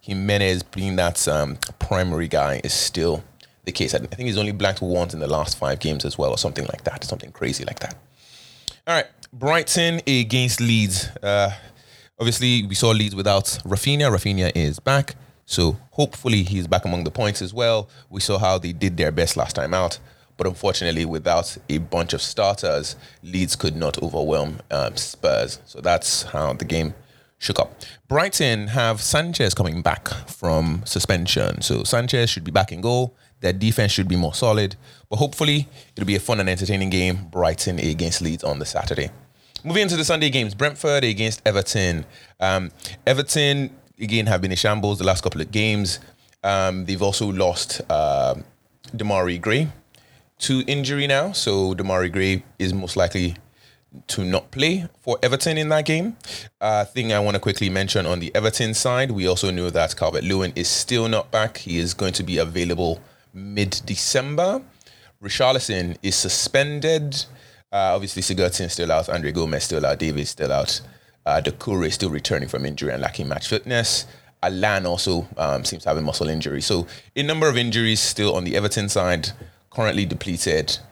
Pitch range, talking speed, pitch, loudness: 90-125 Hz, 180 wpm, 100 Hz, -22 LUFS